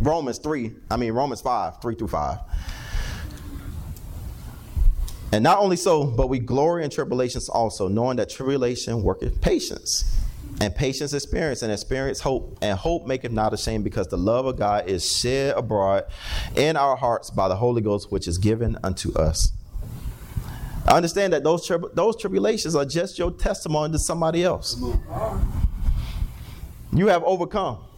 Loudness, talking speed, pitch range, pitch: -24 LUFS, 155 wpm, 100-155 Hz, 120 Hz